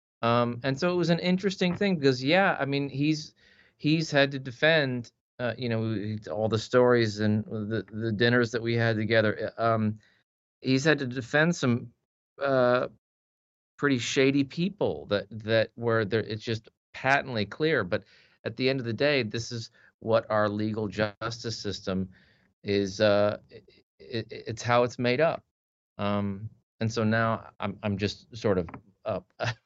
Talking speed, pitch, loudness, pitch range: 165 wpm, 115 Hz, -27 LUFS, 110-135 Hz